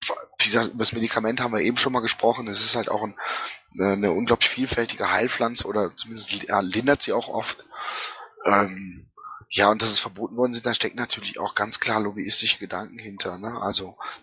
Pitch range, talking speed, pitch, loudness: 100-115 Hz, 175 wpm, 110 Hz, -23 LUFS